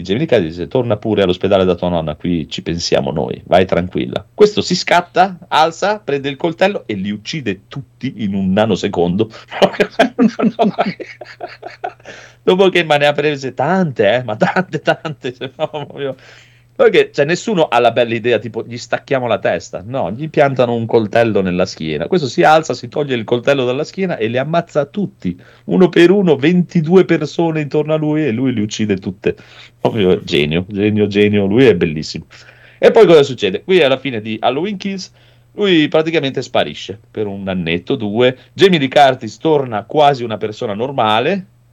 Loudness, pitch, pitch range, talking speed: -15 LUFS, 135 Hz, 115-170 Hz, 165 wpm